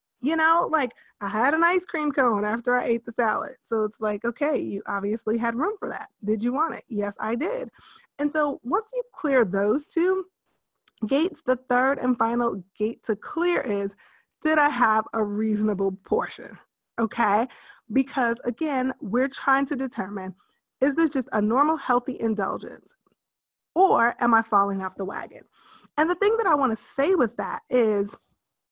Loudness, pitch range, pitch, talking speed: -25 LUFS, 215-300 Hz, 245 Hz, 180 wpm